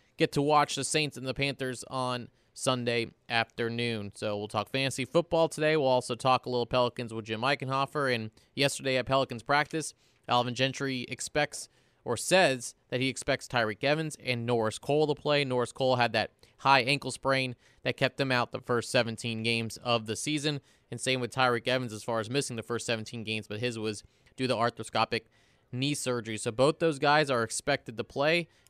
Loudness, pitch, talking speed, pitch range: -29 LUFS, 125 Hz, 195 wpm, 115-135 Hz